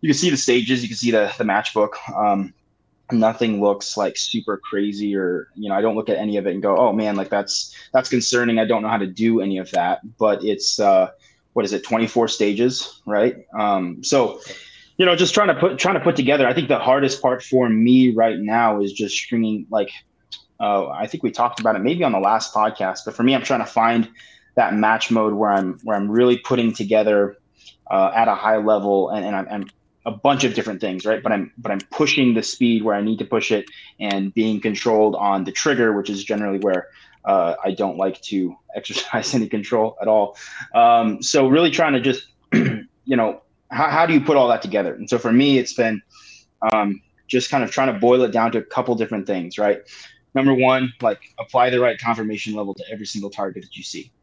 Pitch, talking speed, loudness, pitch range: 110 Hz, 230 wpm, -19 LUFS, 105-125 Hz